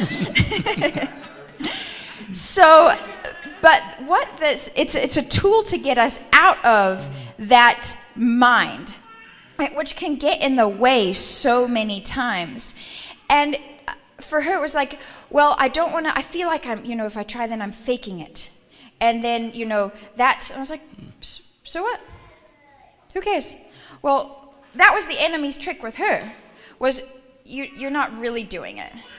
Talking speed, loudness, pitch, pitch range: 155 wpm, -18 LUFS, 270 Hz, 230-305 Hz